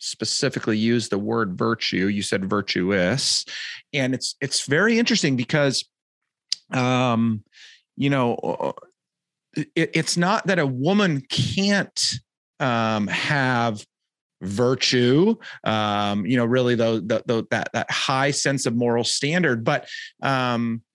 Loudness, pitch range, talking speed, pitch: -22 LUFS, 115-145 Hz, 115 wpm, 125 Hz